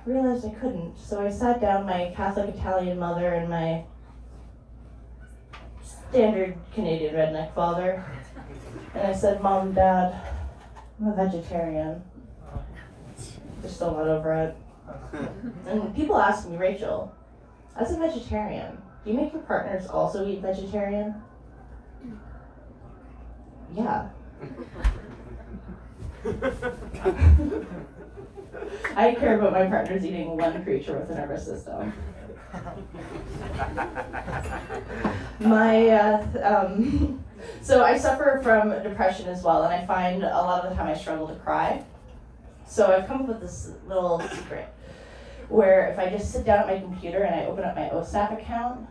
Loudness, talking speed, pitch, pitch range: -25 LUFS, 130 wpm, 190 Hz, 165-210 Hz